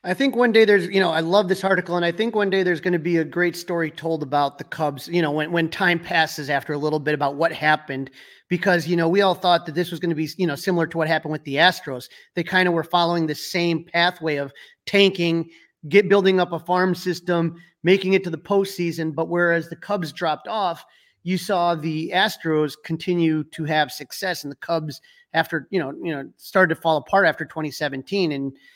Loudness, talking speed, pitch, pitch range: -21 LUFS, 235 wpm, 170 Hz, 155-185 Hz